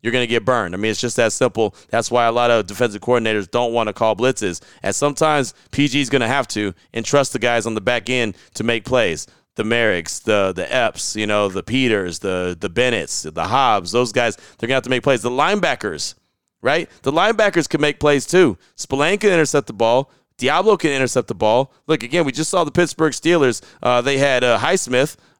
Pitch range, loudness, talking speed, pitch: 115-145 Hz, -18 LUFS, 230 wpm, 125 Hz